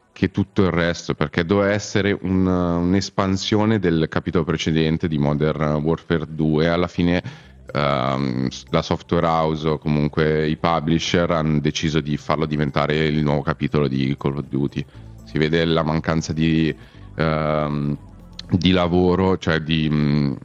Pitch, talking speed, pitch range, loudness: 80 Hz, 145 wpm, 75-90 Hz, -20 LUFS